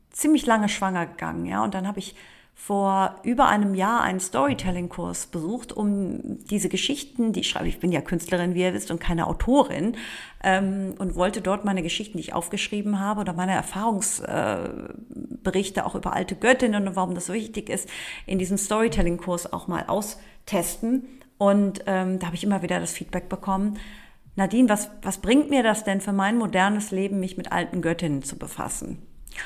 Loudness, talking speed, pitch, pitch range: -25 LUFS, 180 wpm, 195 Hz, 185-215 Hz